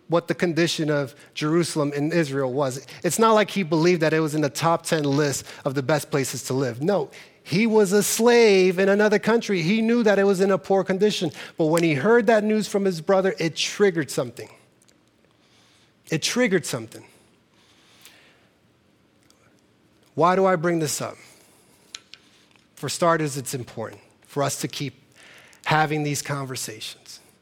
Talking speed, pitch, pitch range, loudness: 165 wpm, 165 Hz, 145-195 Hz, -22 LUFS